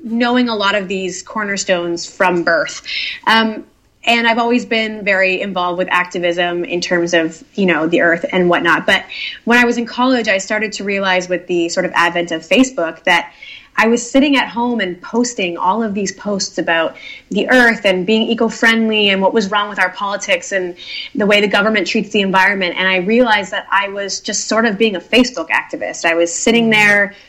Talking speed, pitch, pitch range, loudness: 205 wpm, 200 Hz, 180-225 Hz, -14 LUFS